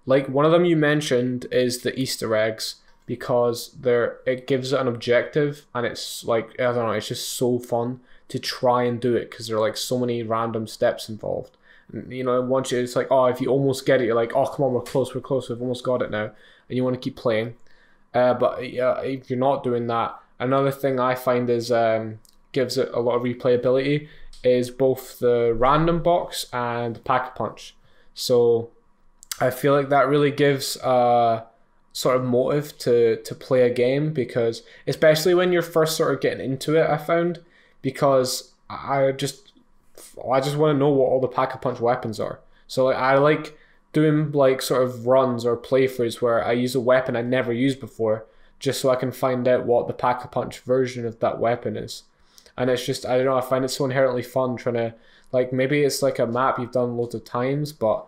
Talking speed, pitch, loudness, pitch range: 215 wpm, 125 Hz, -22 LUFS, 120-135 Hz